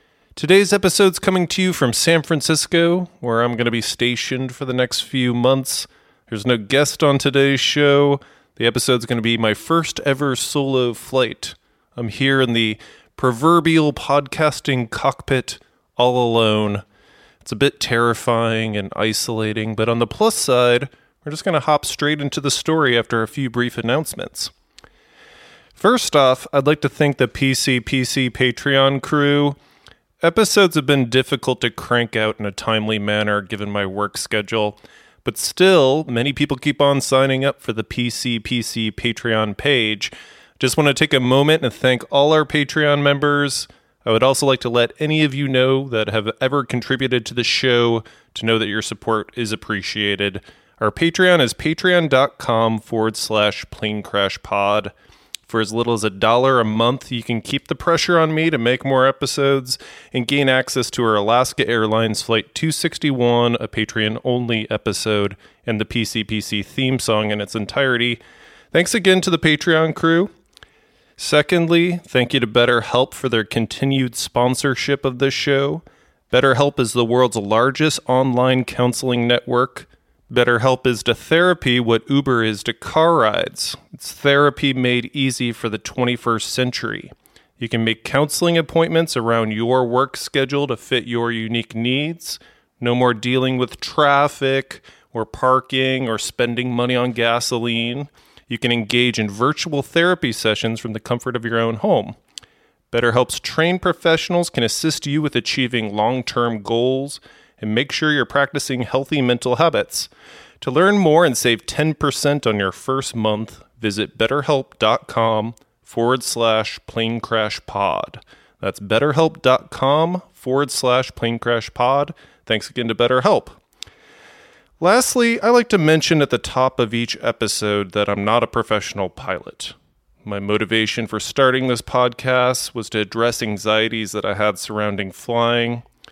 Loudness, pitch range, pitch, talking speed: -18 LUFS, 115-140 Hz, 125 Hz, 155 wpm